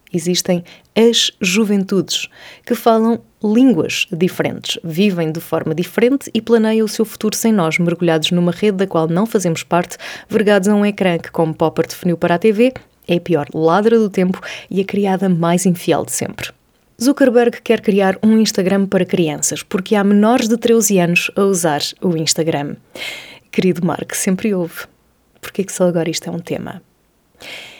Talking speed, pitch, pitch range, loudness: 175 wpm, 195 Hz, 170-220 Hz, -16 LUFS